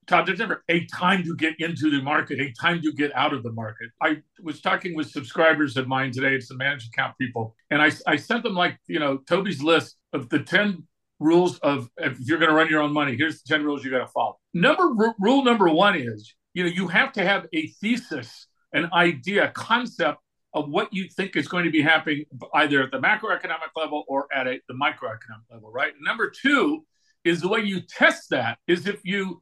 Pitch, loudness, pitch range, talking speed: 160 Hz, -23 LUFS, 140-190 Hz, 225 wpm